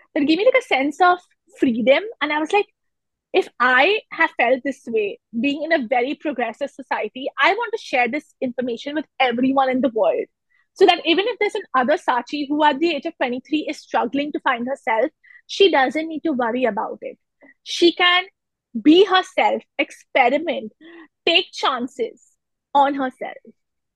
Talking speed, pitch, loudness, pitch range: 180 wpm, 300 Hz, -20 LUFS, 265-370 Hz